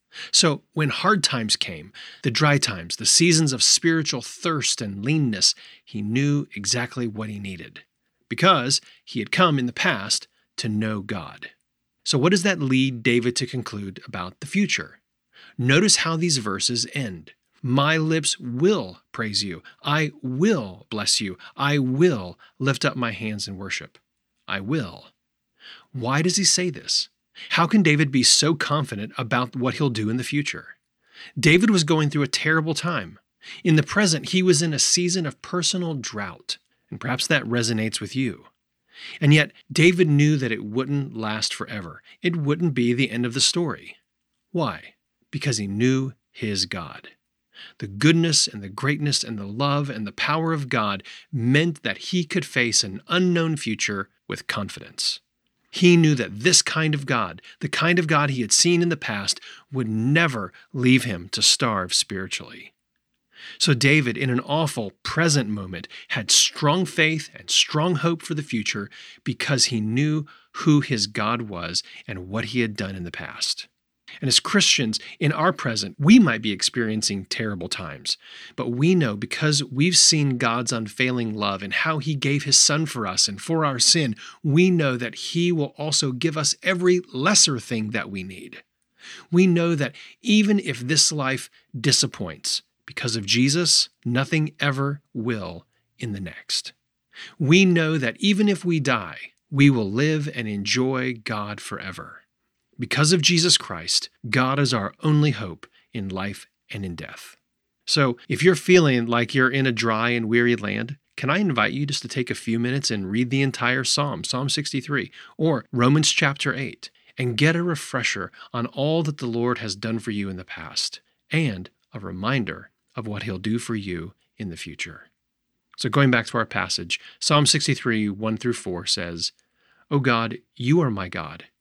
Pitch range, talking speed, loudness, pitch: 115-155 Hz, 175 wpm, -21 LUFS, 130 Hz